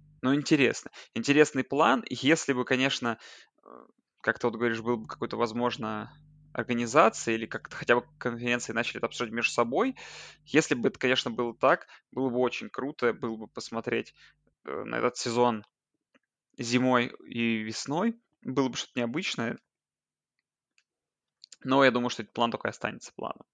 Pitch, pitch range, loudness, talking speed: 120 Hz, 120-135 Hz, -28 LUFS, 145 wpm